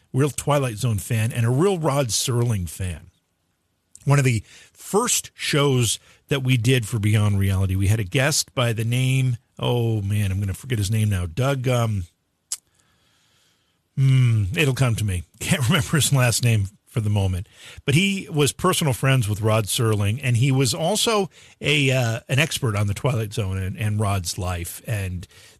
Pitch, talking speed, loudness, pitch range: 115 Hz, 180 wpm, -22 LUFS, 100-135 Hz